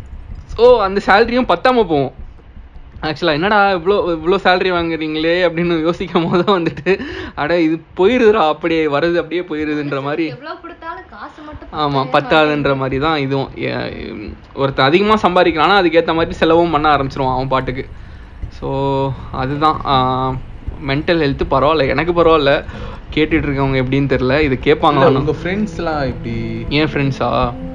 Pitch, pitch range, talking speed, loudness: 155 Hz, 135-175 Hz, 120 wpm, -15 LUFS